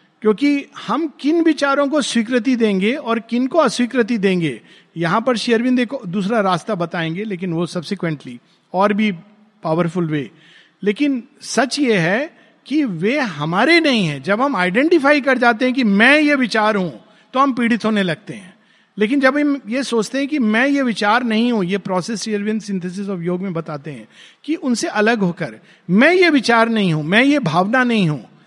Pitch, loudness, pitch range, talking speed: 220 Hz, -17 LUFS, 185-260 Hz, 180 wpm